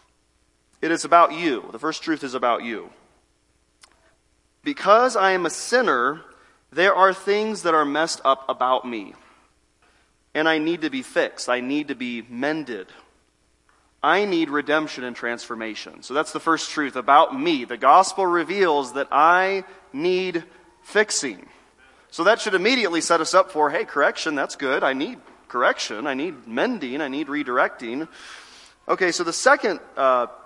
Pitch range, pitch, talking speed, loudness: 125-190 Hz, 155 Hz, 160 wpm, -21 LUFS